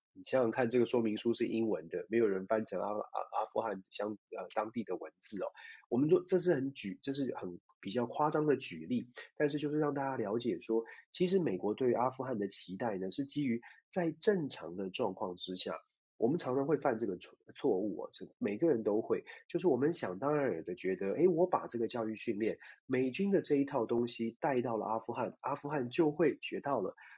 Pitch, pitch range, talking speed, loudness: 120 Hz, 110-145 Hz, 310 characters per minute, -35 LUFS